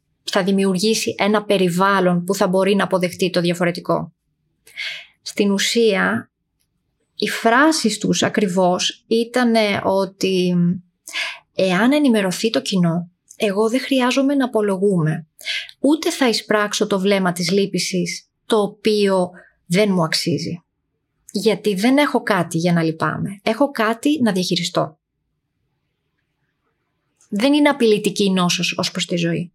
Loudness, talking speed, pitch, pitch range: -18 LUFS, 120 wpm, 195 Hz, 175-220 Hz